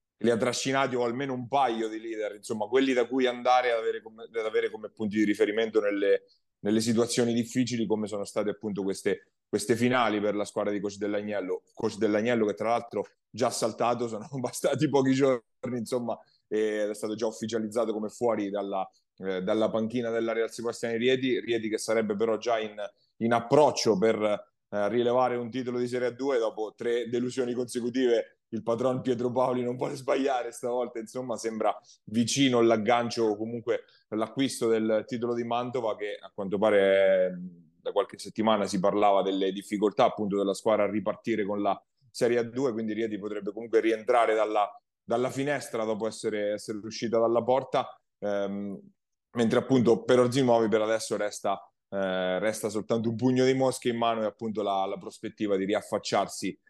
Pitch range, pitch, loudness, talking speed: 105-125 Hz, 115 Hz, -28 LUFS, 175 wpm